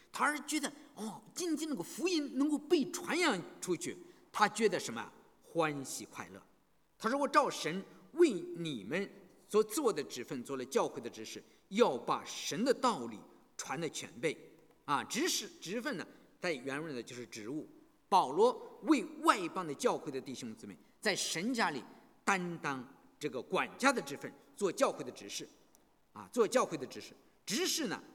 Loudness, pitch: -35 LUFS, 280 Hz